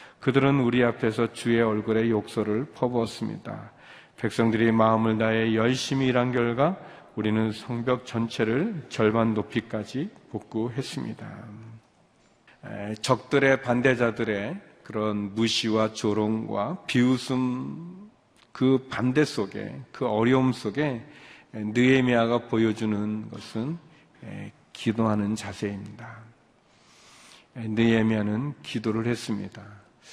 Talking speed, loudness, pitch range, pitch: 240 characters per minute, -26 LUFS, 110-130 Hz, 115 Hz